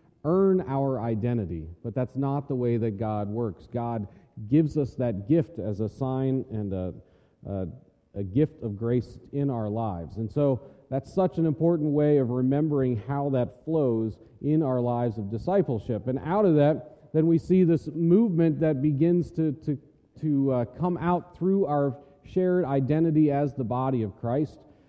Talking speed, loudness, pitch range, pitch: 175 wpm, -26 LUFS, 115-155 Hz, 135 Hz